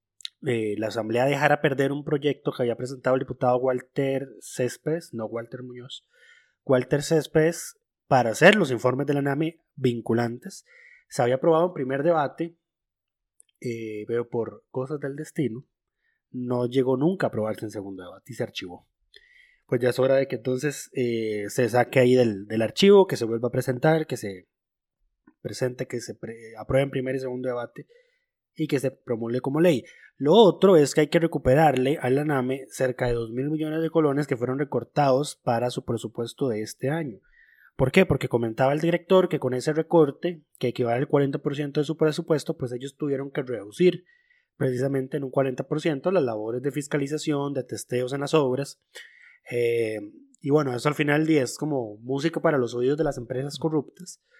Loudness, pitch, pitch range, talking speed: -25 LUFS, 135 Hz, 125-155 Hz, 185 wpm